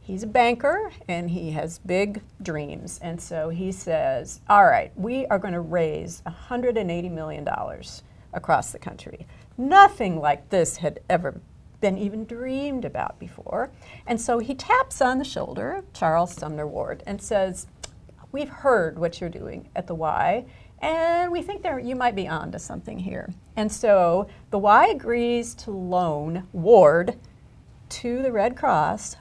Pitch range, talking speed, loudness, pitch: 175-255 Hz, 160 wpm, -23 LUFS, 205 Hz